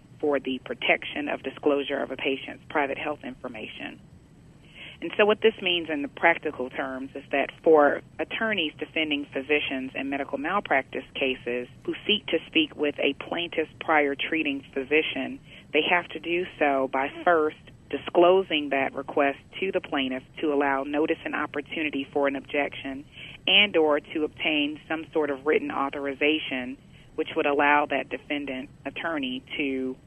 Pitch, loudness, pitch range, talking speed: 145 Hz, -26 LUFS, 135-160 Hz, 155 wpm